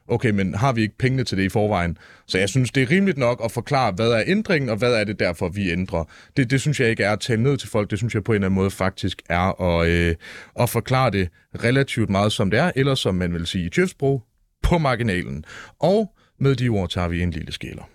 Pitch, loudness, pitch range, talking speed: 110 Hz, -21 LUFS, 95-130 Hz, 260 wpm